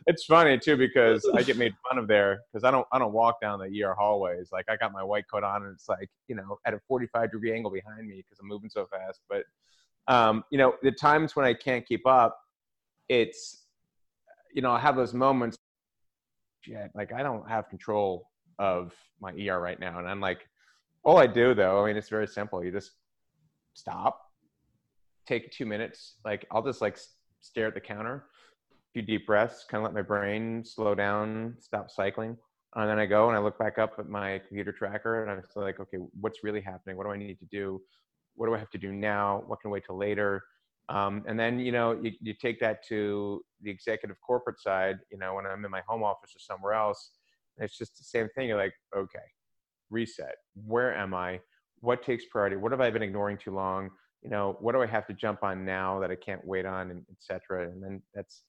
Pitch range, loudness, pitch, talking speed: 100-115 Hz, -29 LUFS, 105 Hz, 225 wpm